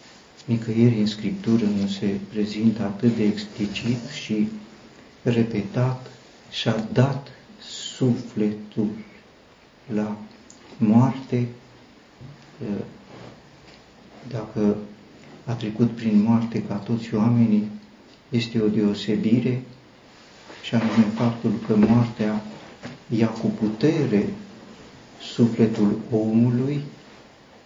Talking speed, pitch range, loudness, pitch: 80 wpm, 105-120 Hz, -23 LUFS, 115 Hz